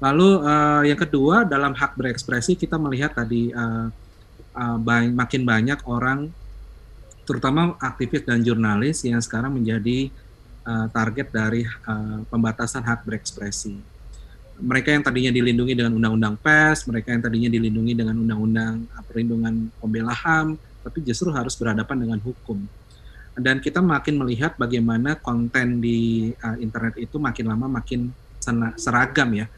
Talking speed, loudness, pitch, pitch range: 140 wpm, -22 LUFS, 120 Hz, 115-135 Hz